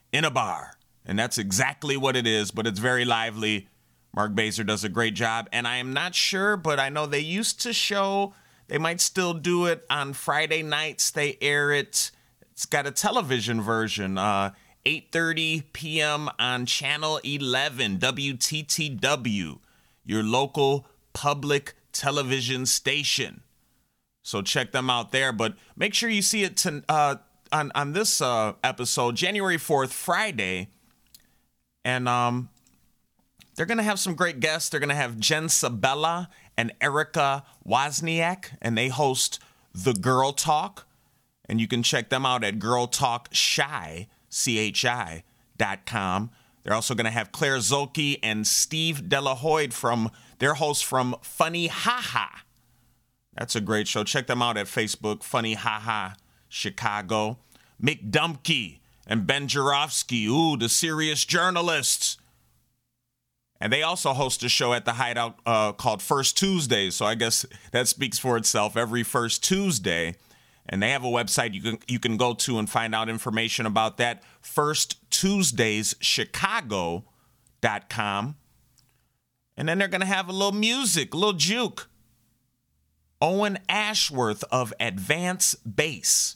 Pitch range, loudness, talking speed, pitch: 115-155 Hz, -25 LUFS, 140 wpm, 130 Hz